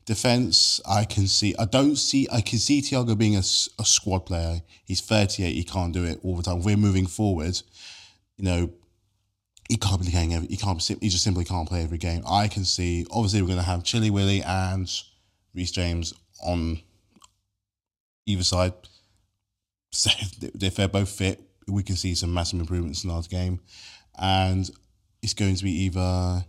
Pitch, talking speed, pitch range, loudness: 95 Hz, 180 wpm, 90-100 Hz, -24 LUFS